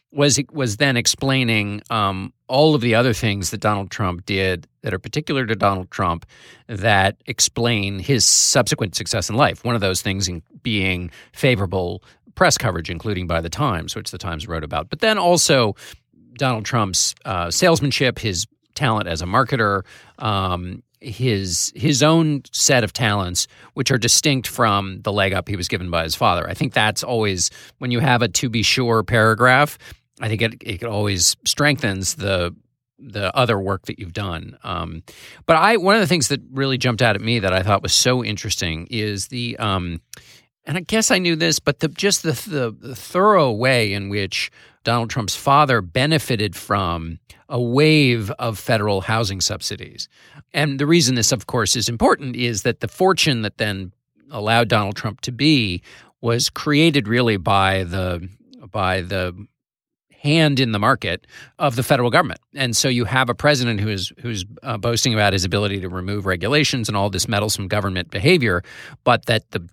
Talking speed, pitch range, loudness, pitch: 180 wpm, 100-130 Hz, -19 LUFS, 115 Hz